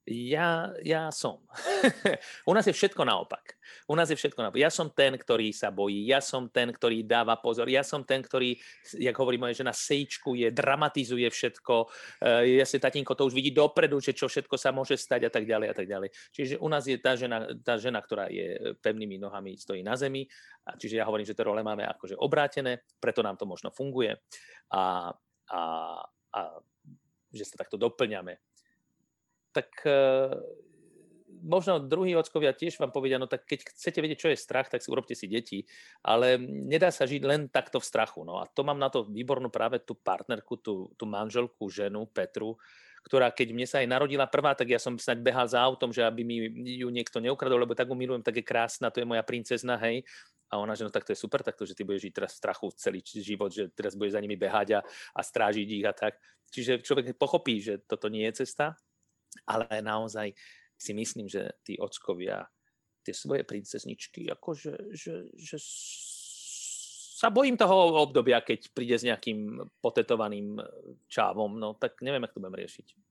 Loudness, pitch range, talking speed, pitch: -30 LUFS, 110-140 Hz, 195 wpm, 125 Hz